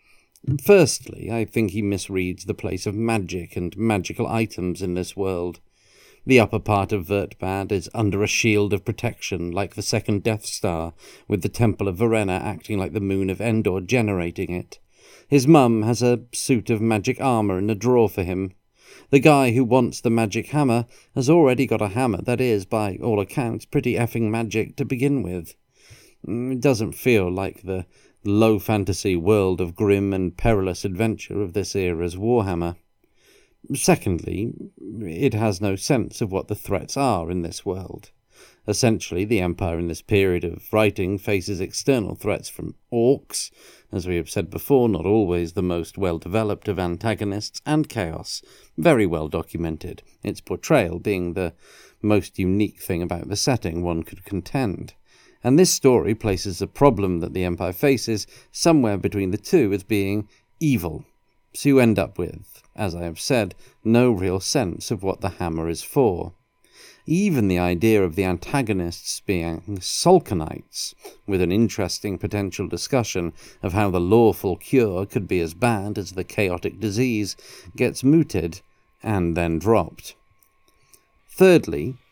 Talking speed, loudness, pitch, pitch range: 160 wpm, -22 LUFS, 105 Hz, 90-115 Hz